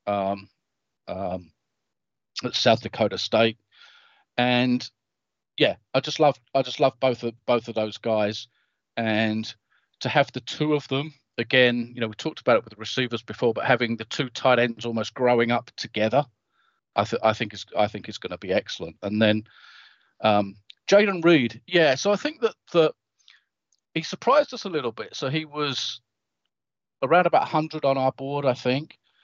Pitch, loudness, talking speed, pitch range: 120 Hz, -24 LUFS, 180 wpm, 110-145 Hz